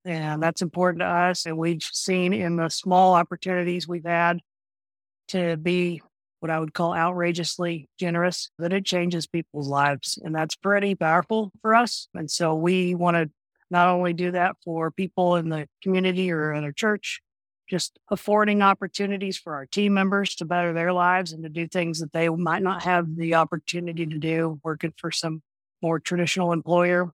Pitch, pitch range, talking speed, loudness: 175 Hz, 165-180 Hz, 180 wpm, -24 LUFS